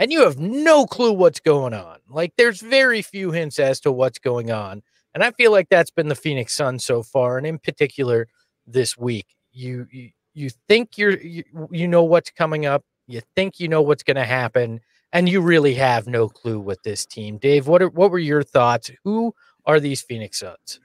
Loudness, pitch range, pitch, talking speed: -19 LUFS, 125-175 Hz, 145 Hz, 215 wpm